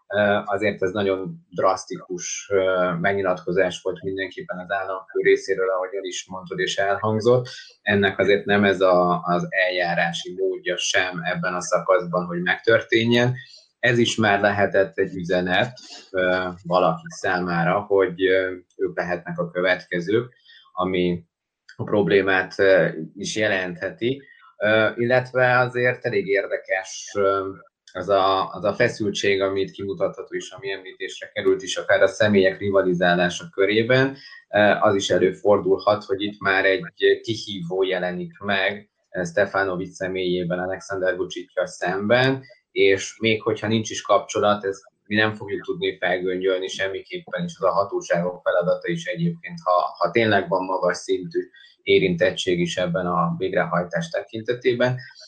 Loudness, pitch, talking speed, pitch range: -22 LUFS, 100 Hz, 125 wpm, 90-125 Hz